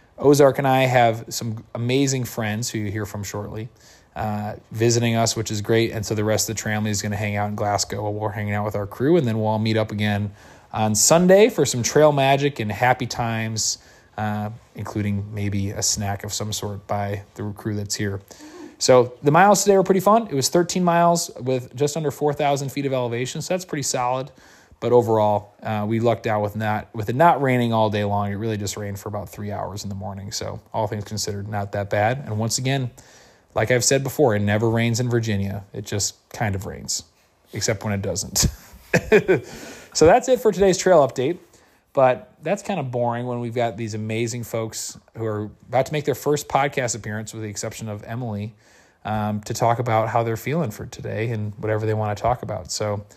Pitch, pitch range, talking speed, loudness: 110 Hz, 105-125 Hz, 220 wpm, -22 LUFS